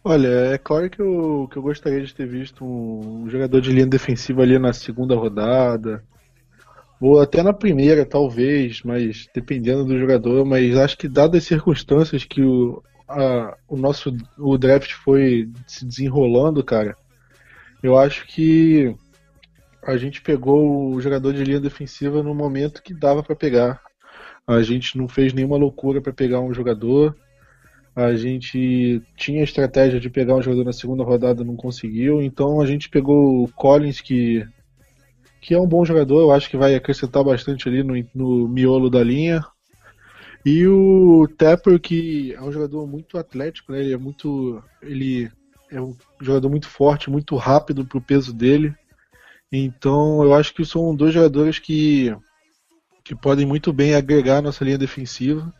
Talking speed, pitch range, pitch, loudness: 165 wpm, 125-145 Hz, 135 Hz, -18 LUFS